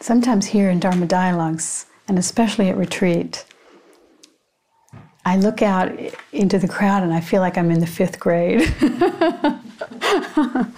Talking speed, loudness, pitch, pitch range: 135 wpm, -19 LUFS, 195 Hz, 180-235 Hz